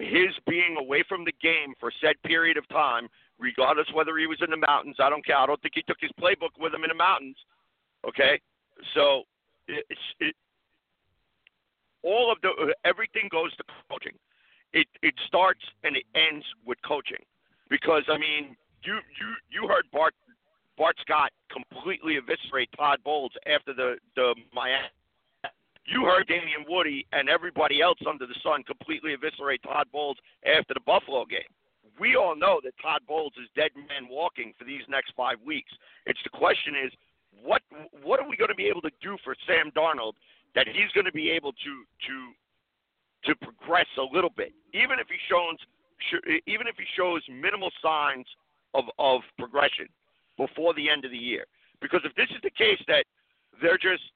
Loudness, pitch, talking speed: -26 LUFS, 165 Hz, 180 wpm